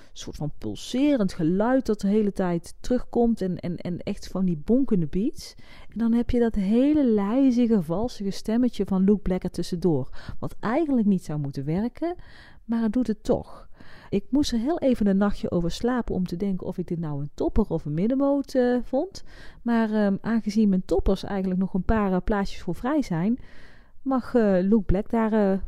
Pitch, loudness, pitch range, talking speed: 210 Hz, -25 LUFS, 185-240 Hz, 200 wpm